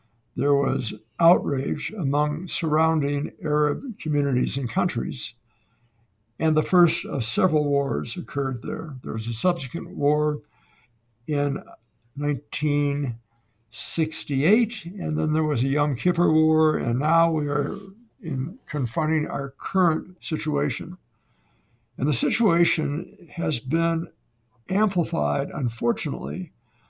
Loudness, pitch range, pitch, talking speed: -24 LUFS, 135-165 Hz, 150 Hz, 105 wpm